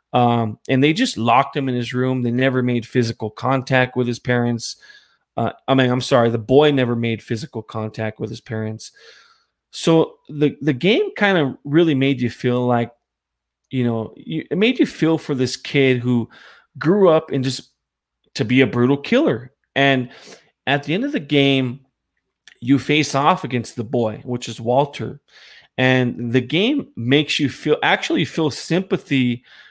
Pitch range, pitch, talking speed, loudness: 120-145 Hz, 130 Hz, 175 wpm, -19 LUFS